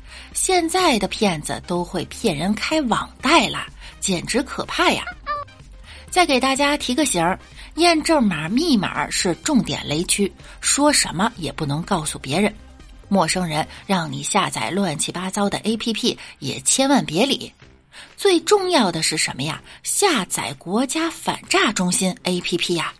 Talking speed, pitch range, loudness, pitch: 225 characters per minute, 175-290 Hz, -20 LUFS, 205 Hz